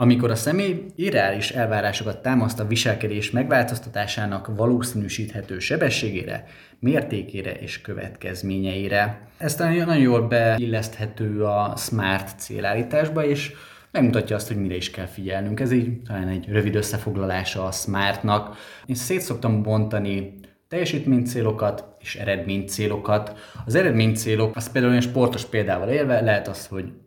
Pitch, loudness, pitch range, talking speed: 110 Hz, -23 LUFS, 100-120 Hz, 130 wpm